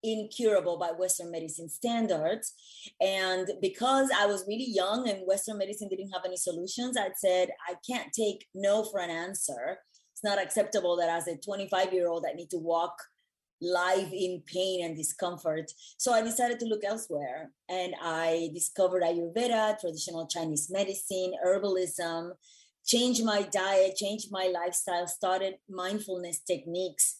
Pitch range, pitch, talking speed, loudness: 175-205 Hz, 185 Hz, 150 wpm, -30 LUFS